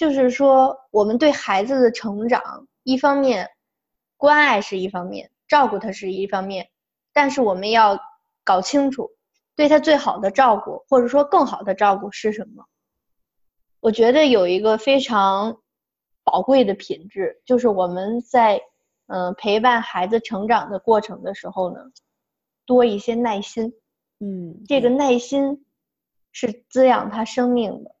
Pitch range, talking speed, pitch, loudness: 205-275 Hz, 220 characters per minute, 235 Hz, -19 LUFS